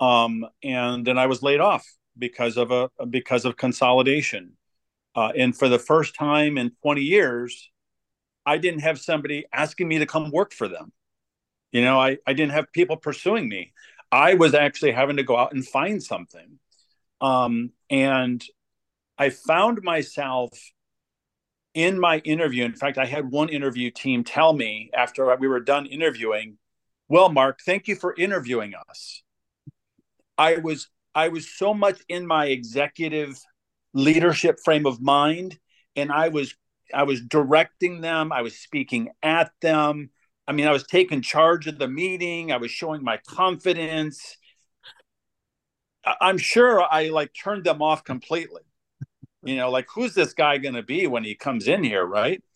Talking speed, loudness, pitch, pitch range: 165 wpm, -22 LUFS, 145 Hz, 130-160 Hz